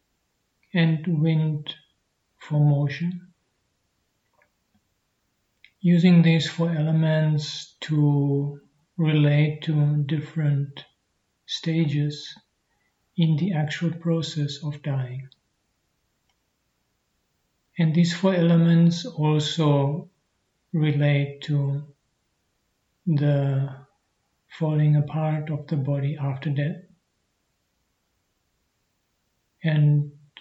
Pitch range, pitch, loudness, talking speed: 145-165 Hz, 150 Hz, -23 LUFS, 70 wpm